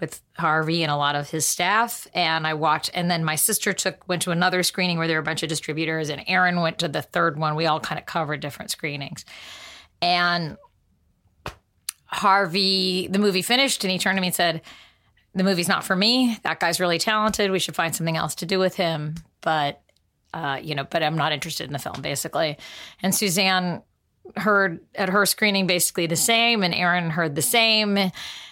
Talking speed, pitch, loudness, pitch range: 205 wpm, 175 Hz, -22 LUFS, 160-195 Hz